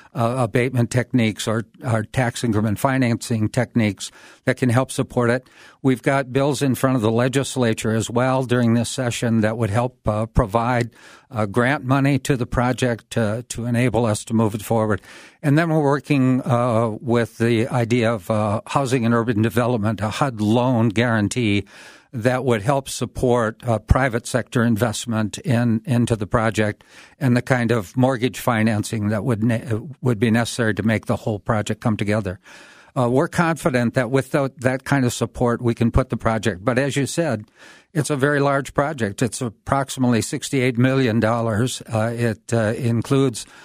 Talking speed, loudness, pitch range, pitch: 175 wpm, -21 LUFS, 110-130 Hz, 120 Hz